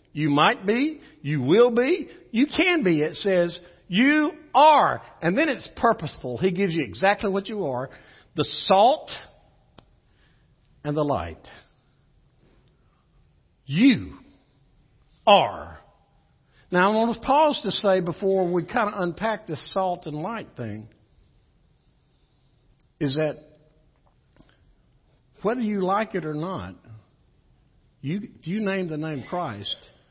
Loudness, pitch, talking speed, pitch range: -23 LUFS, 185 Hz, 125 wpm, 150-220 Hz